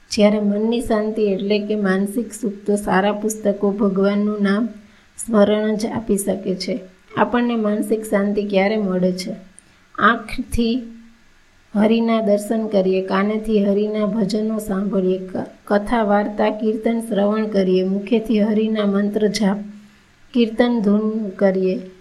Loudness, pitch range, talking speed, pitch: -19 LUFS, 200-220 Hz, 115 wpm, 210 Hz